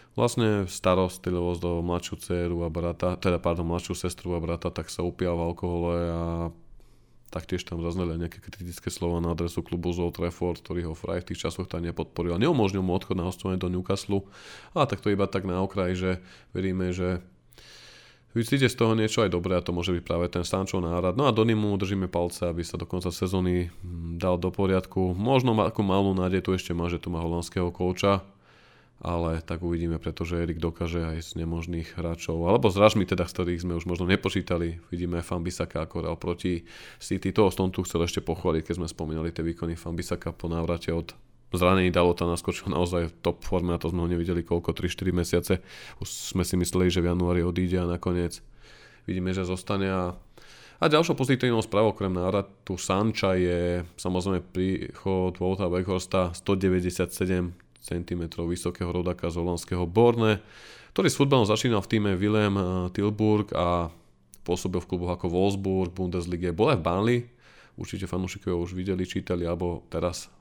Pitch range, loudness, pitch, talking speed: 85-95 Hz, -27 LUFS, 90 Hz, 180 wpm